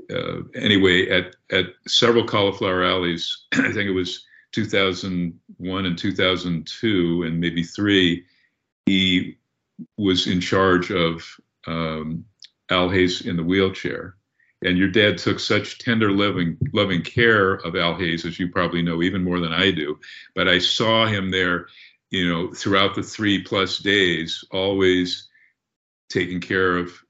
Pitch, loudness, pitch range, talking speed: 90 Hz, -21 LUFS, 85-95 Hz, 145 wpm